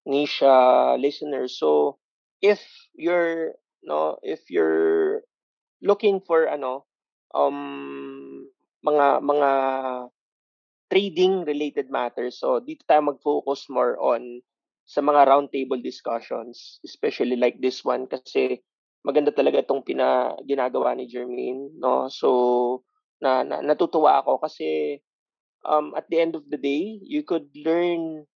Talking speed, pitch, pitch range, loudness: 120 wpm, 145 Hz, 125-175 Hz, -23 LUFS